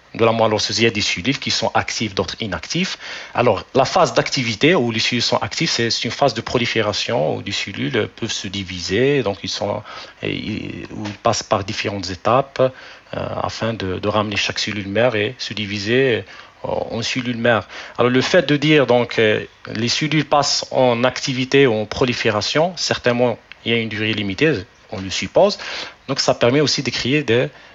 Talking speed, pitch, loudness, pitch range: 185 wpm, 115 Hz, -19 LUFS, 105-130 Hz